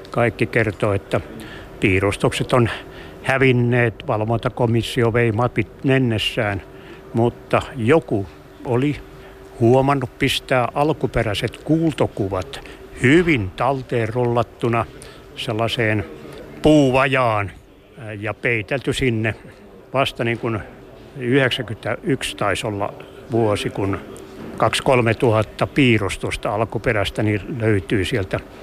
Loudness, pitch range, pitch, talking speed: -20 LUFS, 105-130 Hz, 120 Hz, 80 wpm